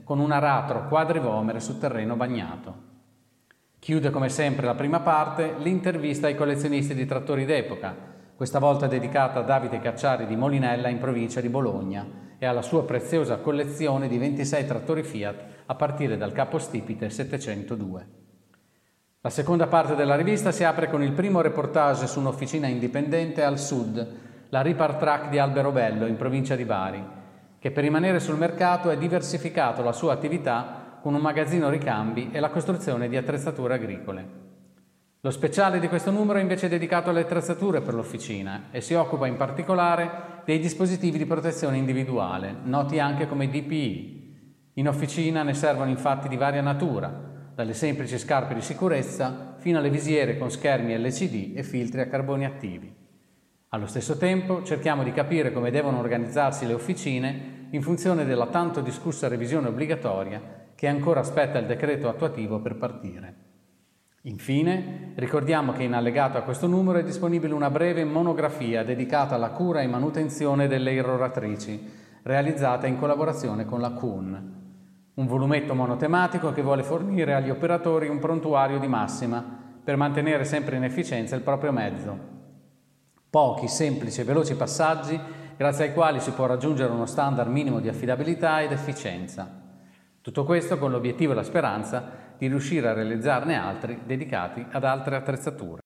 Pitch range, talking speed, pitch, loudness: 120-155 Hz, 155 wpm, 140 Hz, -26 LUFS